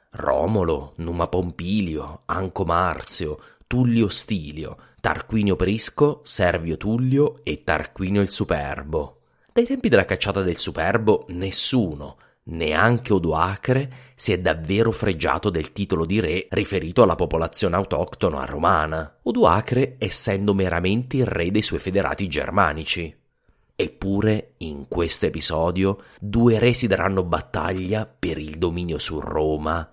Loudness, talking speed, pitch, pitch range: -22 LUFS, 120 wpm, 95 Hz, 85-110 Hz